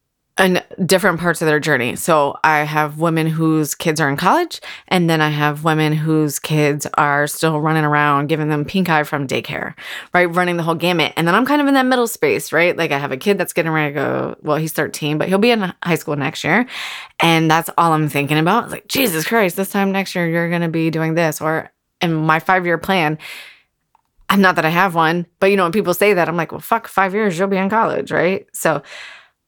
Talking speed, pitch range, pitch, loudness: 240 wpm, 155-190 Hz, 165 Hz, -17 LUFS